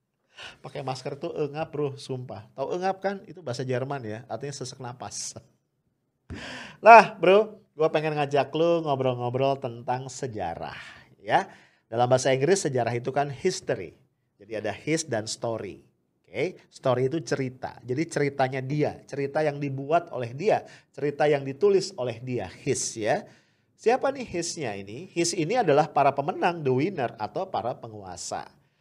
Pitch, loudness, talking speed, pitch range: 140 Hz, -26 LUFS, 150 wpm, 125-160 Hz